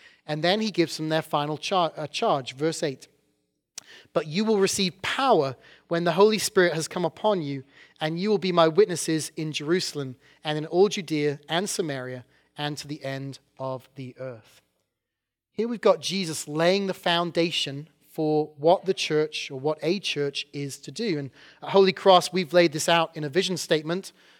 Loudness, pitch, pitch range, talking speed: -25 LUFS, 155 Hz, 145-180 Hz, 185 wpm